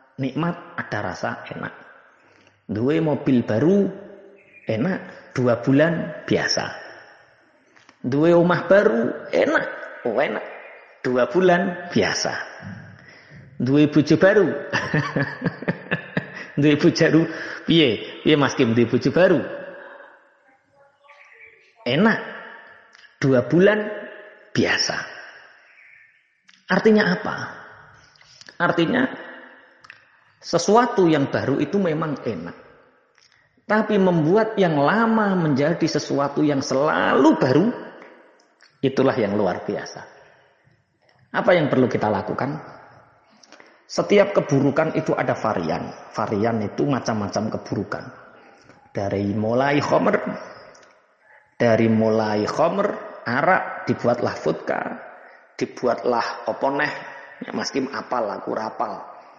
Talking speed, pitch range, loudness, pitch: 85 wpm, 135-200 Hz, -21 LUFS, 160 Hz